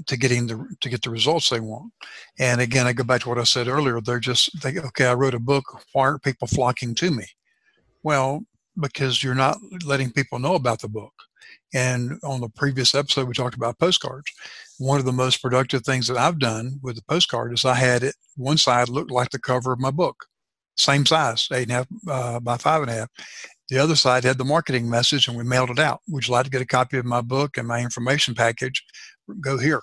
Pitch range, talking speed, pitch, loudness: 120-140 Hz, 235 wpm, 130 Hz, -21 LUFS